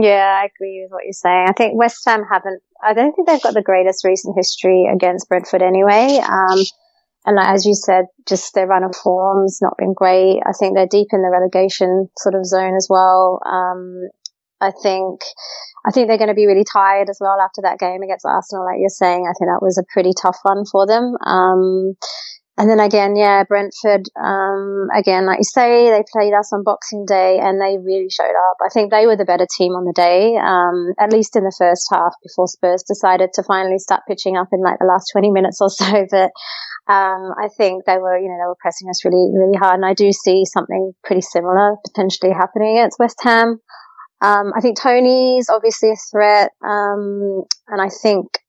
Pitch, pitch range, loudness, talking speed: 195 Hz, 185-210 Hz, -15 LUFS, 215 wpm